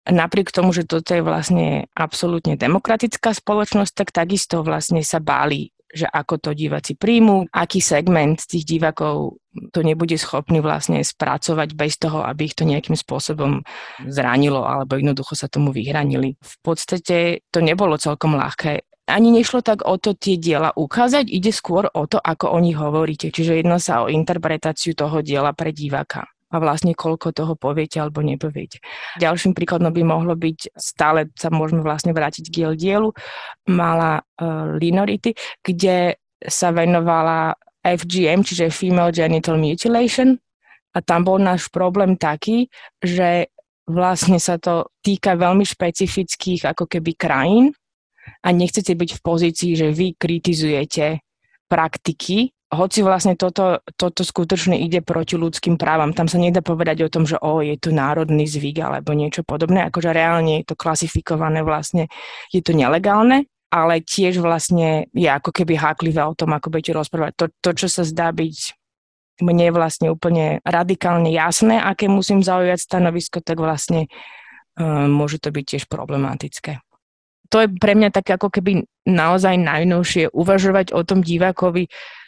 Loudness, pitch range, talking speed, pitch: -18 LUFS, 155-185 Hz, 155 wpm, 170 Hz